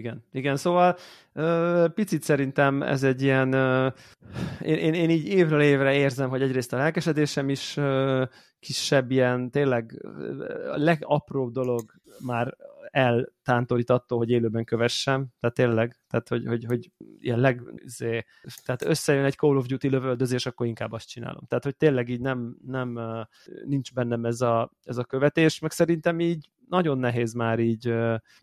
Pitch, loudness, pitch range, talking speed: 130 Hz, -25 LUFS, 120-150 Hz, 150 wpm